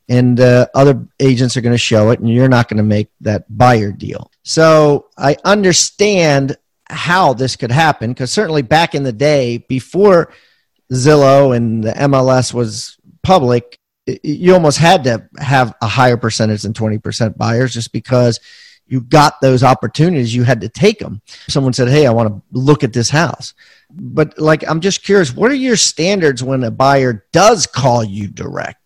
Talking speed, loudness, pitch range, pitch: 180 wpm, -12 LUFS, 120-150 Hz, 130 Hz